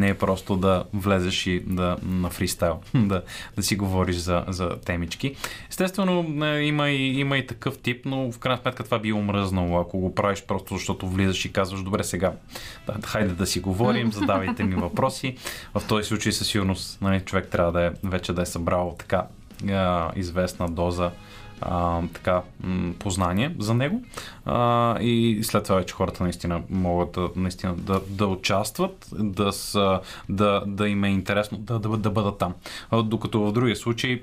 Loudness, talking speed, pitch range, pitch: -25 LUFS, 175 wpm, 90-110 Hz, 100 Hz